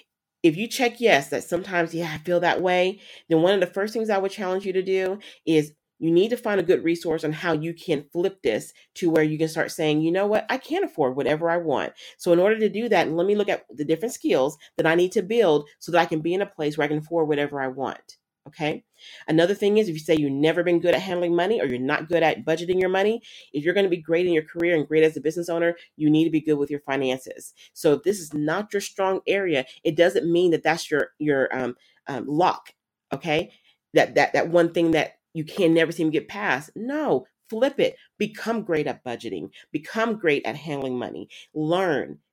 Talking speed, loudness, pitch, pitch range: 250 wpm, -23 LUFS, 170 Hz, 155-195 Hz